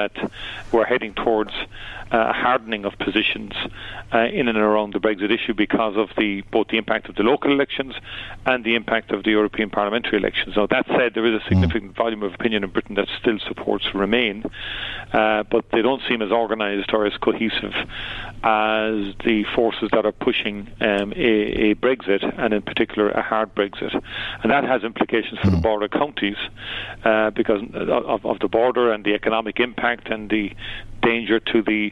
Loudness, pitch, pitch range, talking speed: -21 LUFS, 110 Hz, 105-115 Hz, 185 wpm